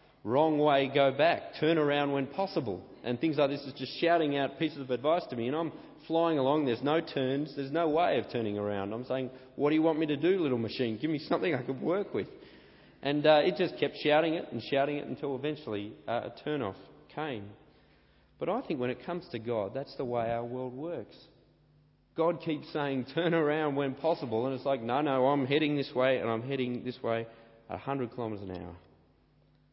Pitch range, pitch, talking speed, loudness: 125-155 Hz, 140 Hz, 220 wpm, -31 LUFS